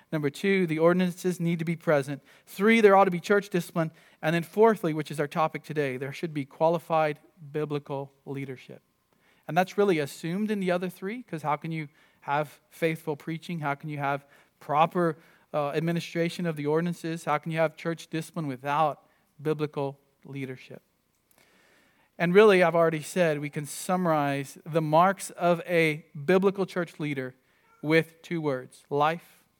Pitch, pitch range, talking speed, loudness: 160 Hz, 145-175 Hz, 165 wpm, -27 LUFS